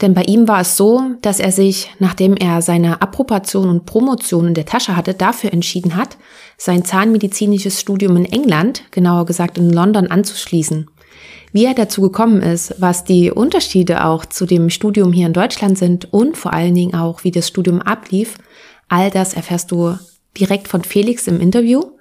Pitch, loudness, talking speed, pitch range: 190 Hz, -14 LUFS, 180 wpm, 175-210 Hz